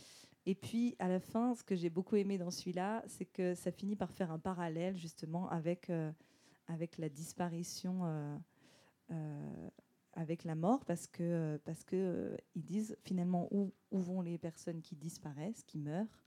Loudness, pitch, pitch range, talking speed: -41 LUFS, 175 Hz, 165-190 Hz, 175 wpm